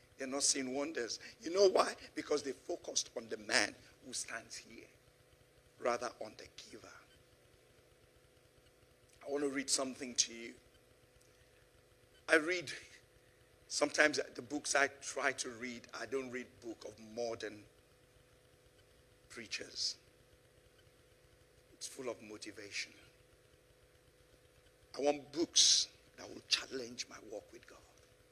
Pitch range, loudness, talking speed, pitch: 125-145 Hz, -36 LUFS, 120 wpm, 135 Hz